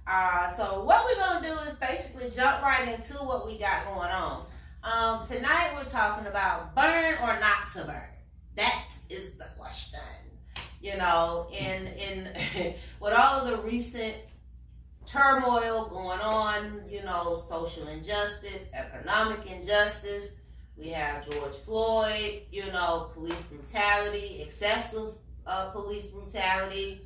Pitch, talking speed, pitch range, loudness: 205 Hz, 135 wpm, 180-230 Hz, -29 LUFS